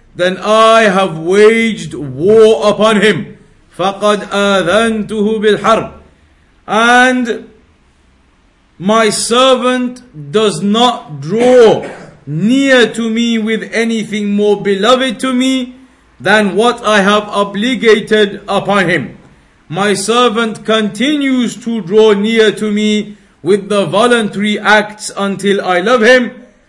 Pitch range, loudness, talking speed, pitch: 200-230 Hz, -11 LUFS, 105 wpm, 210 Hz